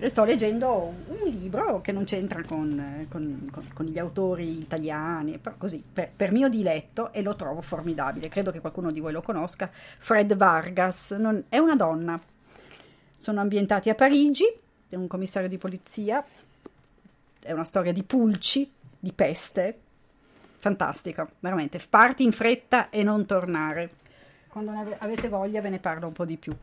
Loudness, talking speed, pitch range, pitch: -26 LUFS, 160 wpm, 165-215 Hz, 190 Hz